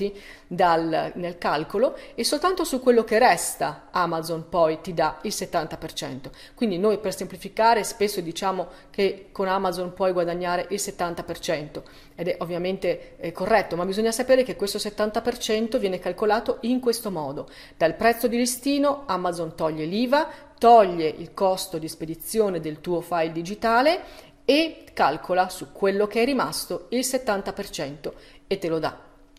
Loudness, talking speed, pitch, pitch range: -24 LUFS, 150 wpm, 195 Hz, 170-230 Hz